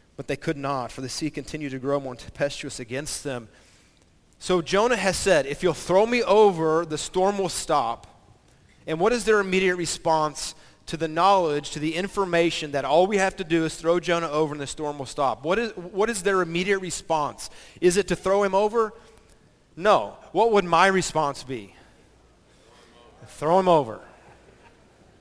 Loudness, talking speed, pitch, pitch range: -24 LUFS, 180 wpm, 165 Hz, 145-190 Hz